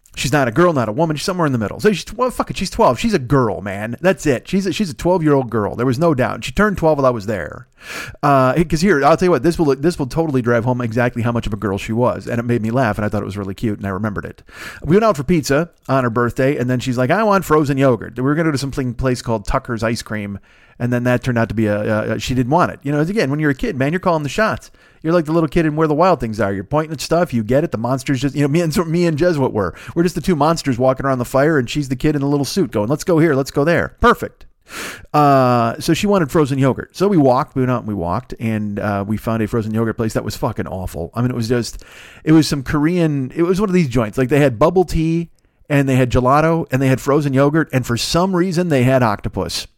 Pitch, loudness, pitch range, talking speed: 135 Hz, -17 LUFS, 120-165 Hz, 305 wpm